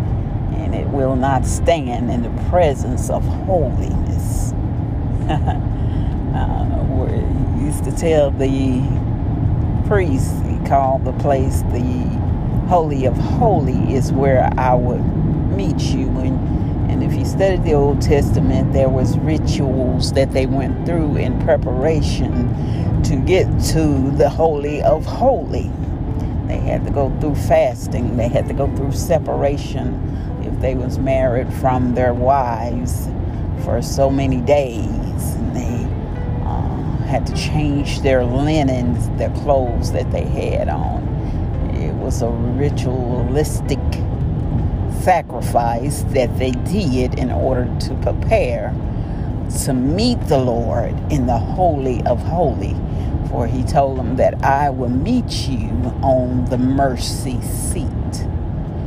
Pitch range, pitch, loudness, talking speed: 110-130 Hz, 125 Hz, -18 LUFS, 130 wpm